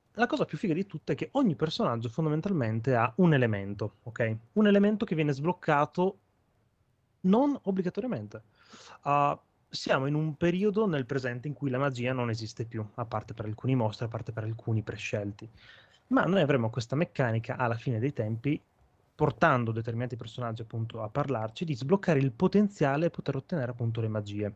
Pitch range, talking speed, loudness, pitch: 115-165 Hz, 175 wpm, -30 LUFS, 130 Hz